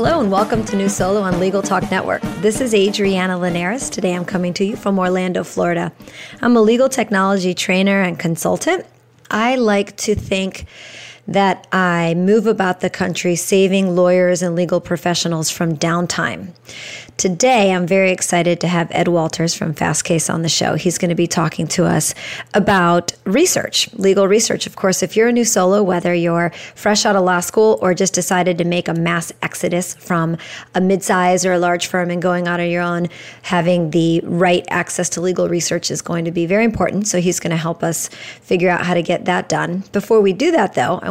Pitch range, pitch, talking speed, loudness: 175-195 Hz, 180 Hz, 200 wpm, -16 LUFS